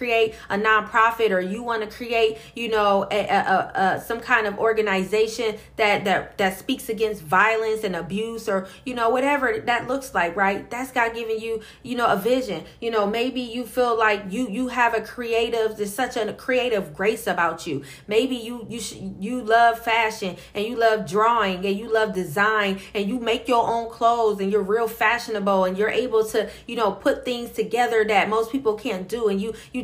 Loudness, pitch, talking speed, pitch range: -22 LUFS, 220 Hz, 205 wpm, 205-235 Hz